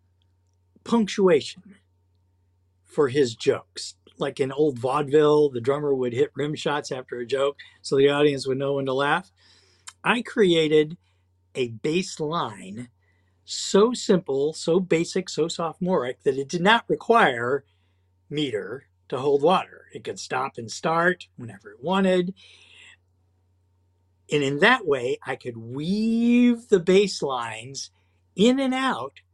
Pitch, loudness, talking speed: 145 Hz, -23 LUFS, 135 wpm